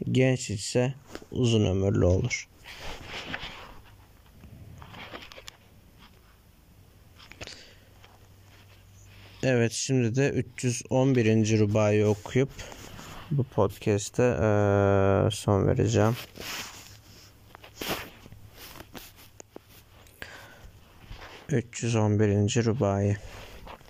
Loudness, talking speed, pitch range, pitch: -26 LUFS, 45 wpm, 100-115 Hz, 105 Hz